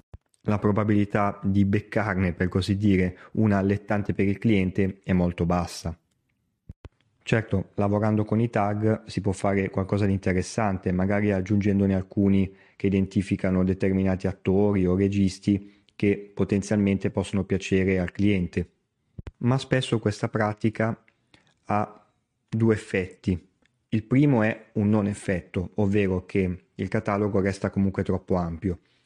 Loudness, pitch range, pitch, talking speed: -25 LUFS, 95-105 Hz, 100 Hz, 130 wpm